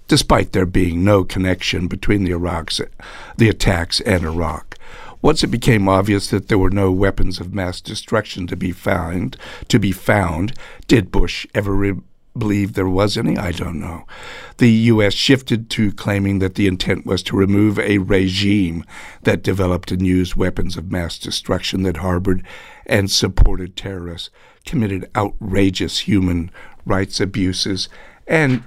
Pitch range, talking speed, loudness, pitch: 90-105 Hz, 155 wpm, -18 LUFS, 95 Hz